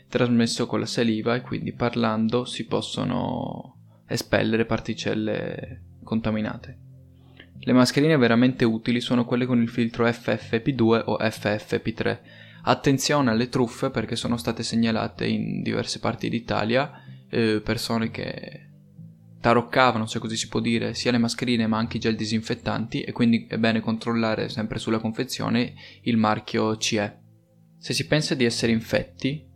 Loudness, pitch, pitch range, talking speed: -24 LUFS, 115 Hz, 110-125 Hz, 140 wpm